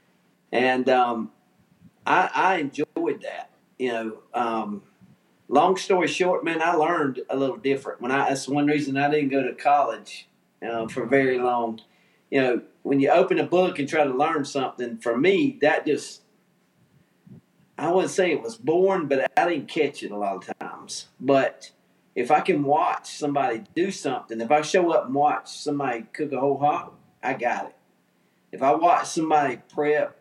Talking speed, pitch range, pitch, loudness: 180 wpm, 130-165 Hz, 145 Hz, -24 LUFS